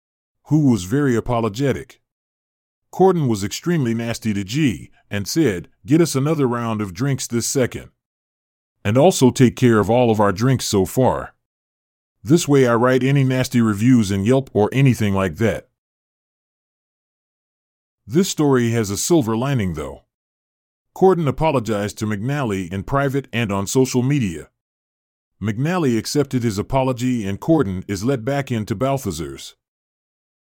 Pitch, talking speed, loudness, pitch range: 120 Hz, 145 wpm, -19 LUFS, 100-135 Hz